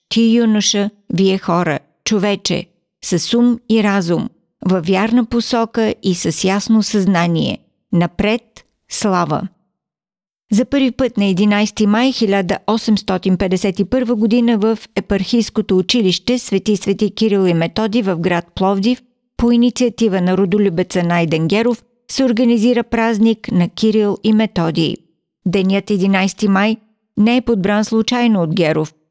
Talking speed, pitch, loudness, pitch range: 125 wpm, 205 Hz, -16 LUFS, 185-230 Hz